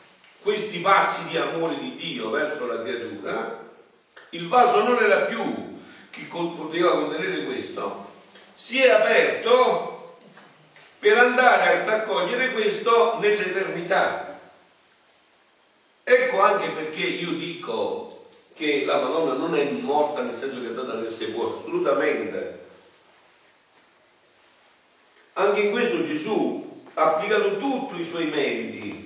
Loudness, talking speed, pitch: -23 LUFS, 115 wpm, 250 Hz